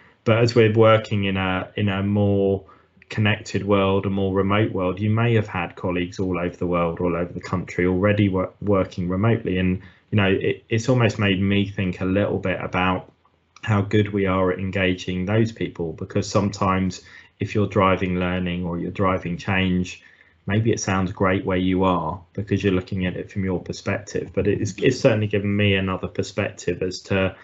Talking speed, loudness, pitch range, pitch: 190 wpm, -22 LUFS, 90-105 Hz, 95 Hz